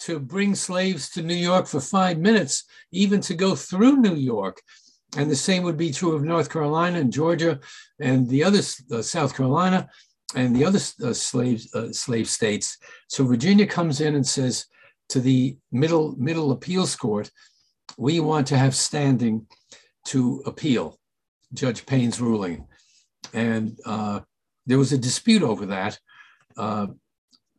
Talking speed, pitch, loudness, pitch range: 155 wpm, 145 Hz, -23 LUFS, 130-175 Hz